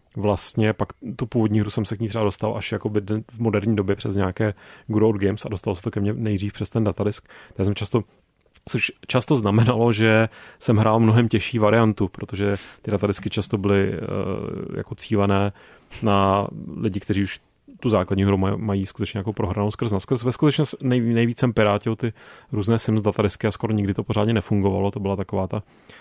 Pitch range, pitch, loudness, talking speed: 100-115 Hz, 105 Hz, -22 LUFS, 190 wpm